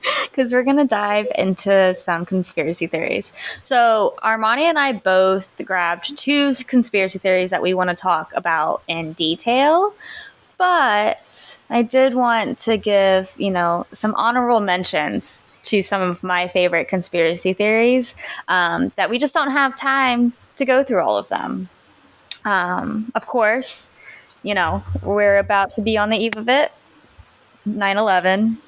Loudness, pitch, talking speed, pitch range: -18 LUFS, 215 Hz, 155 wpm, 185-250 Hz